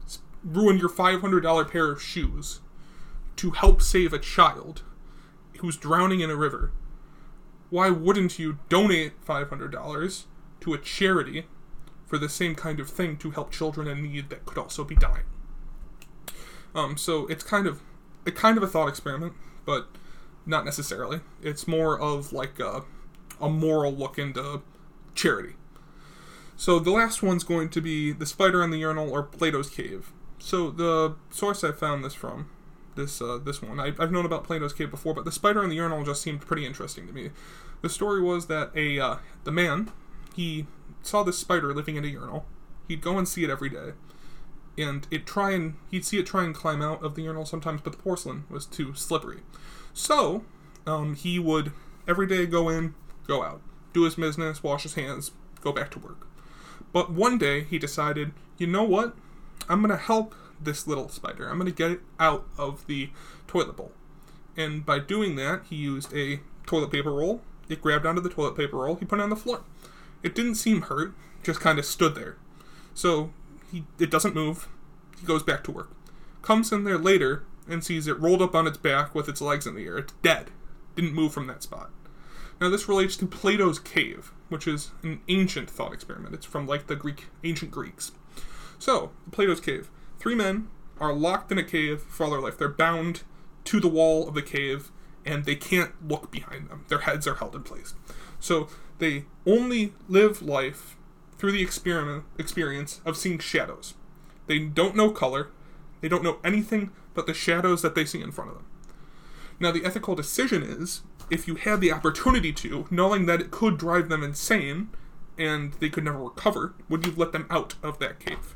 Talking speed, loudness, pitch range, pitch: 195 wpm, -27 LUFS, 150-180 Hz, 165 Hz